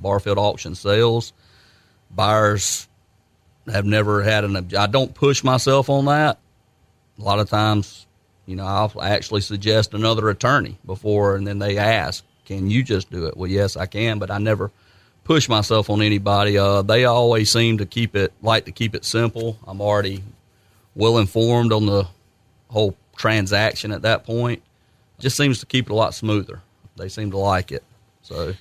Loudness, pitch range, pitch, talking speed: -20 LUFS, 100-115 Hz, 105 Hz, 175 wpm